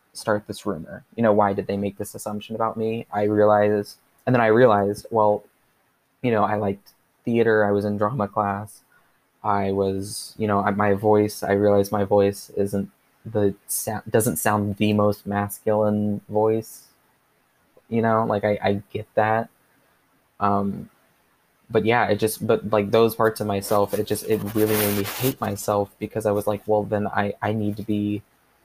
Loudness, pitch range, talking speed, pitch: -22 LUFS, 100-110 Hz, 185 wpm, 105 Hz